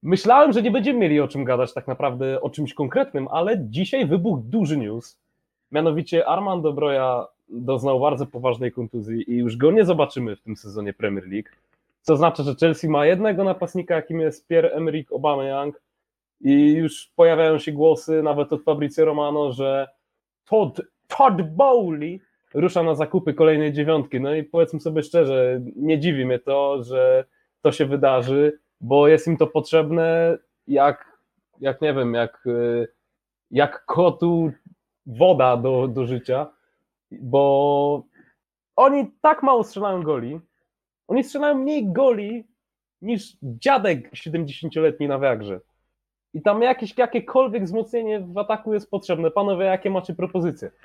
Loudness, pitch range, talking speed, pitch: -21 LUFS, 140-185 Hz, 145 wpm, 155 Hz